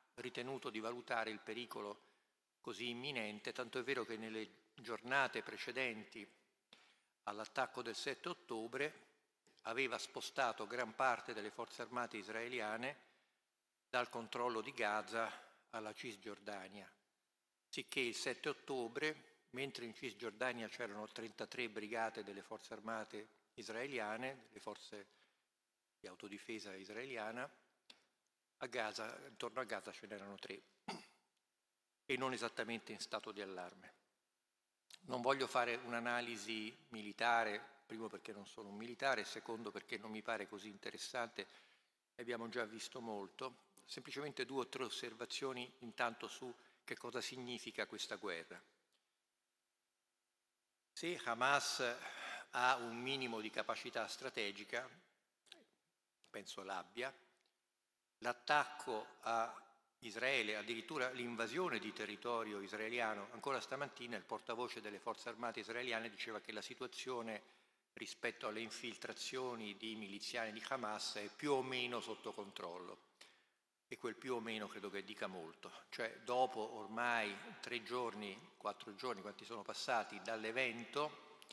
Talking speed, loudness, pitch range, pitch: 120 wpm, -44 LUFS, 110-125 Hz, 115 Hz